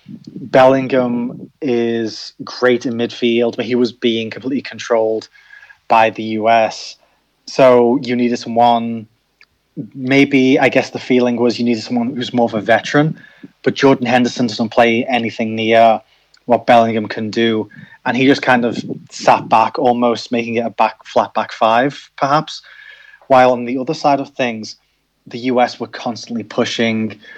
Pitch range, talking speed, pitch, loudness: 115-130 Hz, 155 wpm, 120 Hz, -15 LUFS